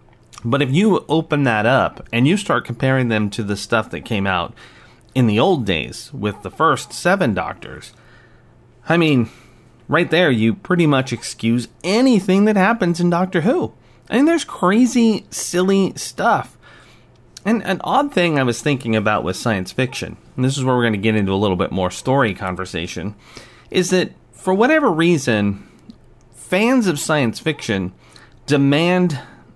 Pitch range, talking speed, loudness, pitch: 110-175 Hz, 165 wpm, -18 LUFS, 130 Hz